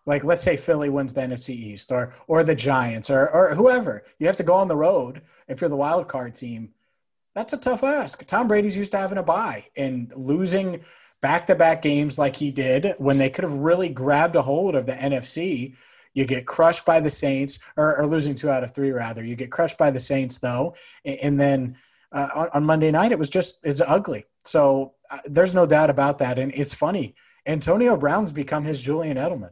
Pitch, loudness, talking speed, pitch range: 145 Hz, -22 LUFS, 220 wpm, 135-170 Hz